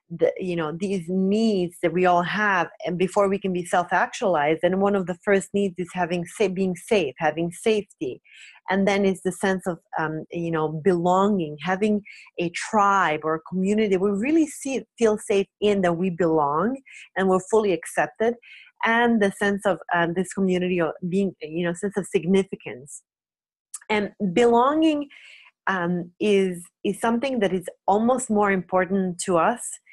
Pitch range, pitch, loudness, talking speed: 175-210 Hz, 190 Hz, -23 LUFS, 170 wpm